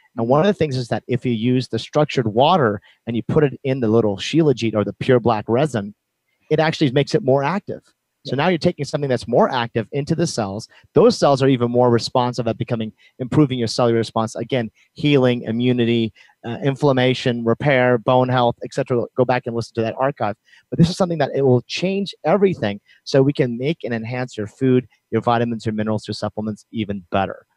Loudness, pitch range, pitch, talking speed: -19 LUFS, 115-140 Hz, 125 Hz, 210 wpm